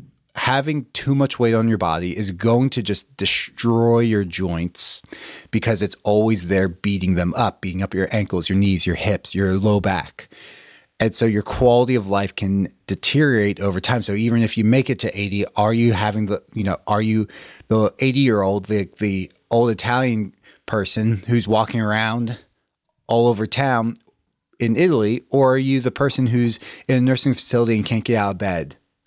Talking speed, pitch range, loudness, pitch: 190 wpm, 100-120 Hz, -20 LUFS, 110 Hz